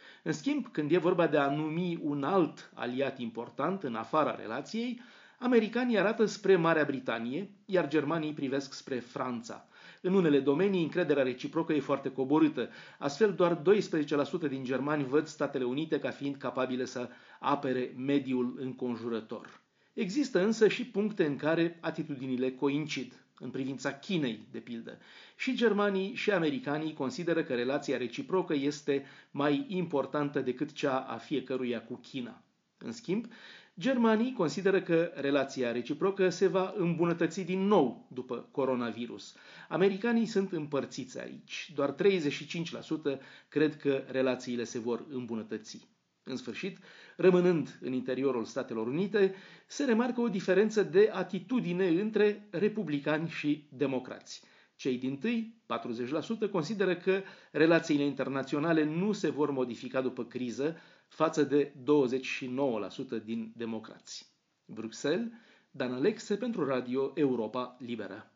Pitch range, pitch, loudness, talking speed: 130-190 Hz, 150 Hz, -31 LUFS, 130 wpm